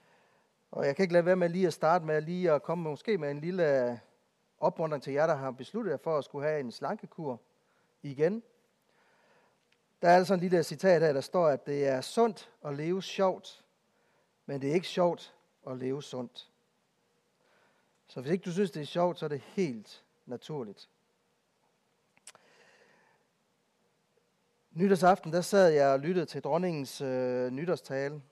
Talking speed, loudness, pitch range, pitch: 170 wpm, -30 LUFS, 140-190 Hz, 165 Hz